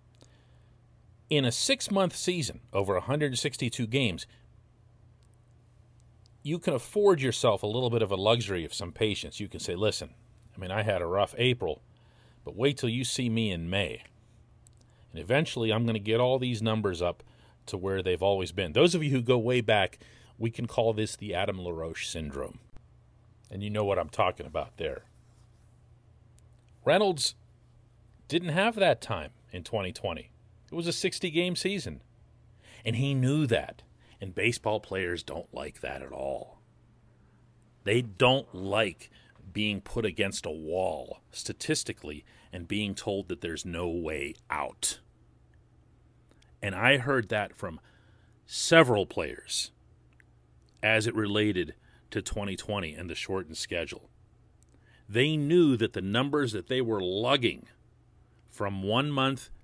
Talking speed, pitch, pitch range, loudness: 150 wpm, 115 Hz, 105-125 Hz, -29 LUFS